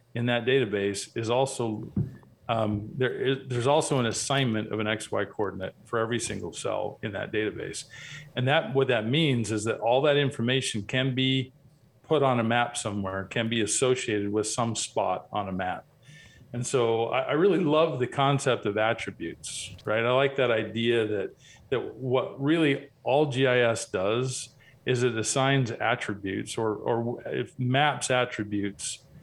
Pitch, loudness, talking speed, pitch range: 120 Hz, -27 LUFS, 165 wpm, 110-135 Hz